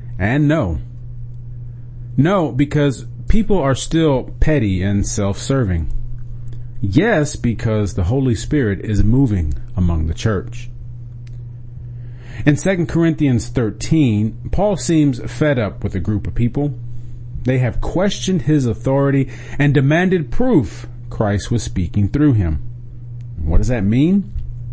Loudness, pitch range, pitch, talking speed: -18 LUFS, 110-145 Hz, 120 Hz, 120 wpm